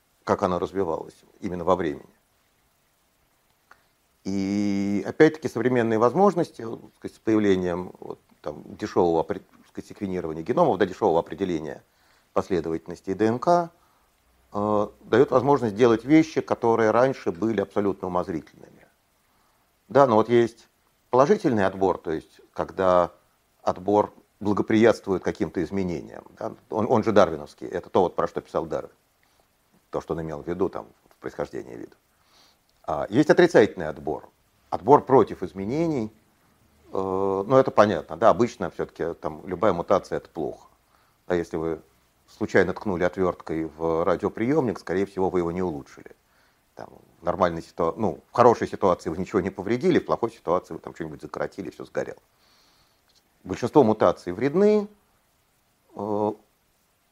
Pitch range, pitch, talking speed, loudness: 90-120 Hz, 105 Hz, 130 wpm, -24 LUFS